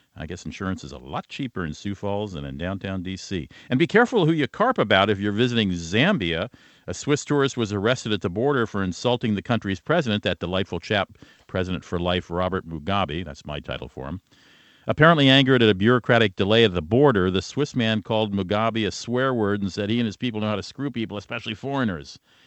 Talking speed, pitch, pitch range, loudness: 215 wpm, 105 Hz, 95-120 Hz, -23 LUFS